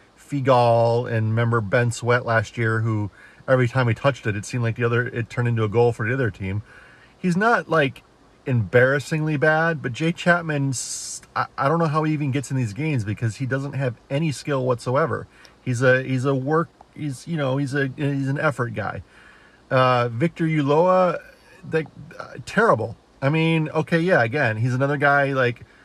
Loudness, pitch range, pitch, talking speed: -22 LUFS, 120-150 Hz, 130 Hz, 190 wpm